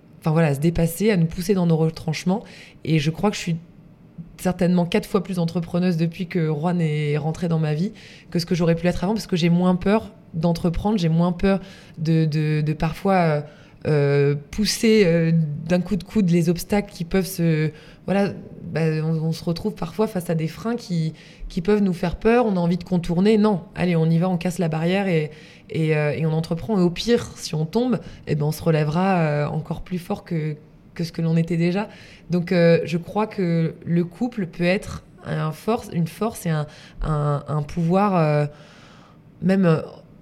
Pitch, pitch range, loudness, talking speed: 170 Hz, 160-190 Hz, -22 LUFS, 210 wpm